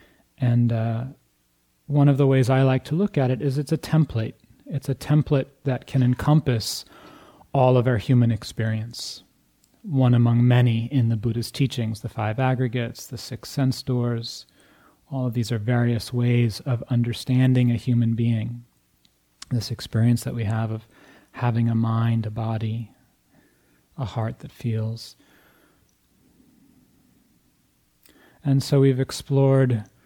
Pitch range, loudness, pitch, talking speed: 115-130 Hz, -23 LUFS, 120 Hz, 140 wpm